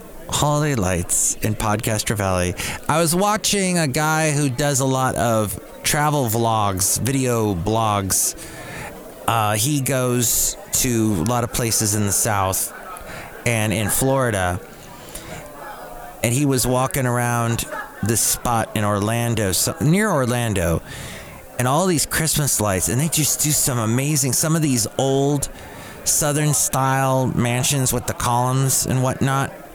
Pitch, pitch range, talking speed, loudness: 125 Hz, 110-140 Hz, 135 wpm, -19 LUFS